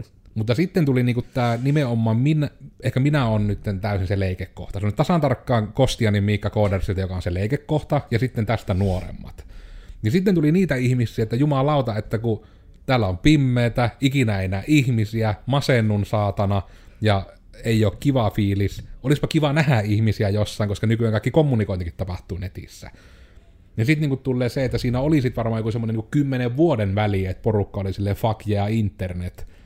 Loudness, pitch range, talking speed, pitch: -22 LUFS, 100-130 Hz, 170 wpm, 110 Hz